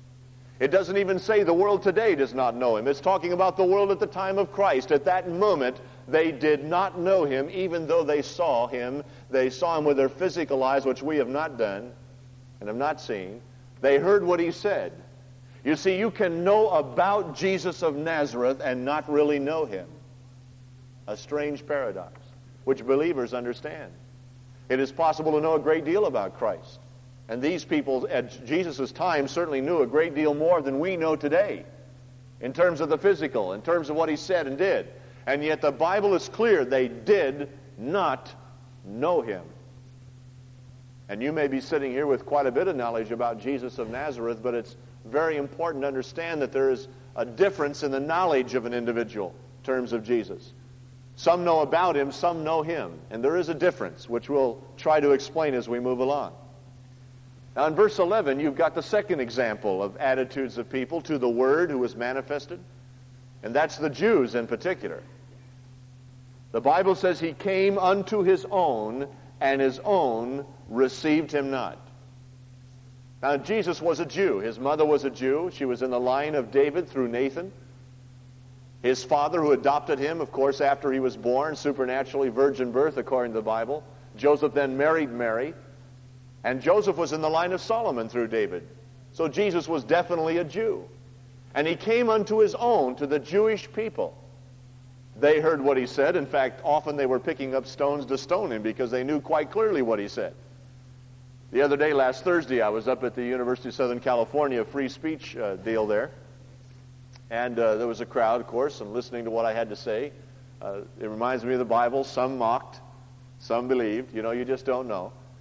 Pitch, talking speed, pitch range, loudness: 135 Hz, 190 wpm, 125-155 Hz, -26 LUFS